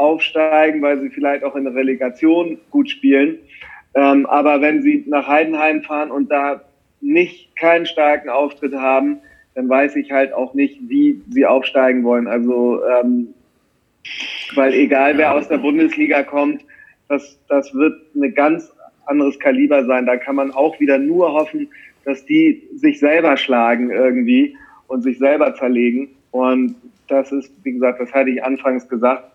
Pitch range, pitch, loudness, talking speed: 135-160 Hz, 145 Hz, -16 LUFS, 160 wpm